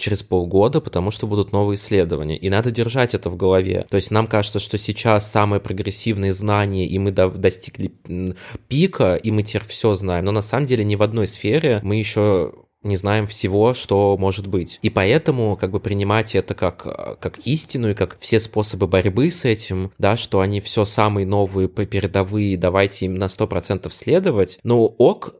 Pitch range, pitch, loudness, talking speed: 95-110 Hz, 100 Hz, -19 LUFS, 185 wpm